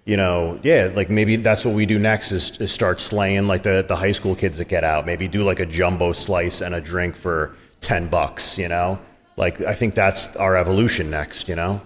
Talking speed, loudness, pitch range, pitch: 235 wpm, -20 LUFS, 85-100 Hz, 95 Hz